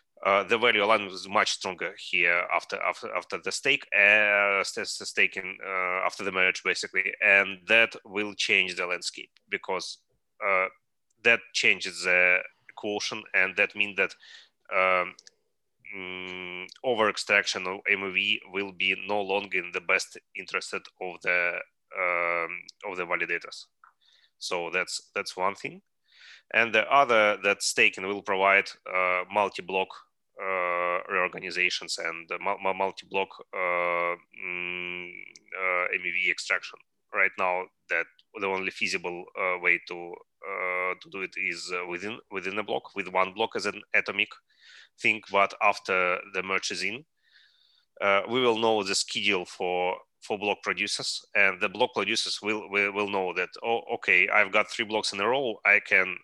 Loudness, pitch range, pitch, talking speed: -26 LUFS, 90-105 Hz, 95 Hz, 150 wpm